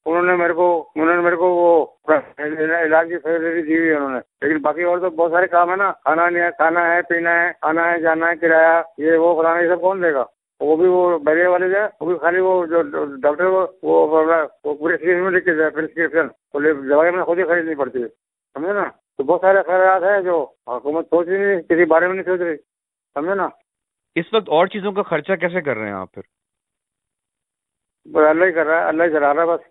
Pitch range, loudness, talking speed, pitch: 160-180 Hz, -17 LUFS, 205 wpm, 170 Hz